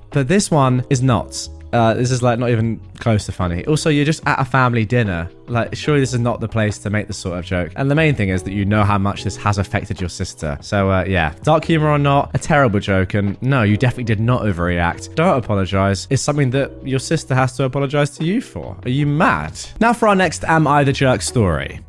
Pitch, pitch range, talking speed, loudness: 115 Hz, 100-140 Hz, 250 wpm, -17 LUFS